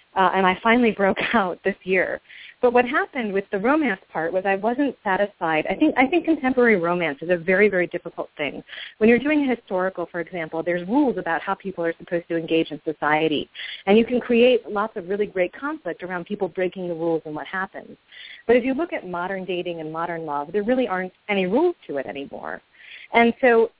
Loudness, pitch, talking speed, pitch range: -22 LUFS, 190 Hz, 215 wpm, 170-235 Hz